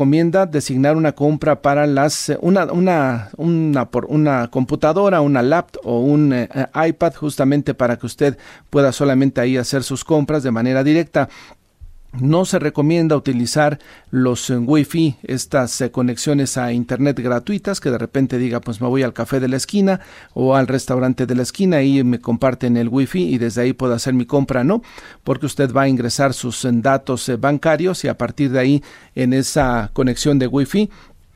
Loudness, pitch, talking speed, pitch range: -17 LUFS, 135 Hz, 180 wpm, 125-150 Hz